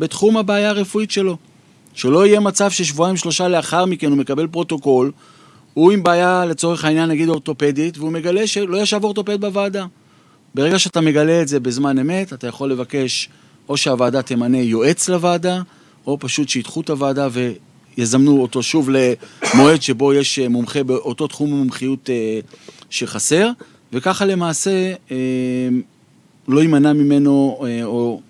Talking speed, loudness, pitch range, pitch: 135 wpm, -17 LUFS, 130-180 Hz, 150 Hz